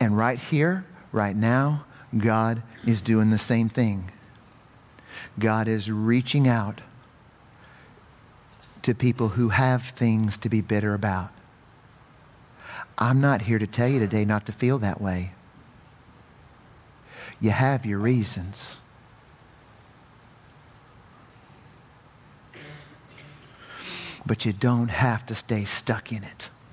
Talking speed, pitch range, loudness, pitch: 110 wpm, 110-130 Hz, -25 LUFS, 115 Hz